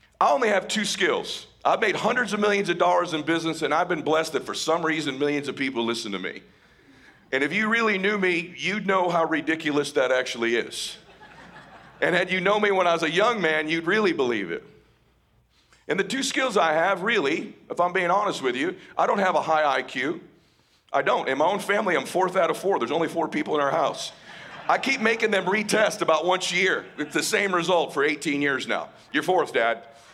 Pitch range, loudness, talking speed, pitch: 155-205 Hz, -24 LUFS, 225 wpm, 175 Hz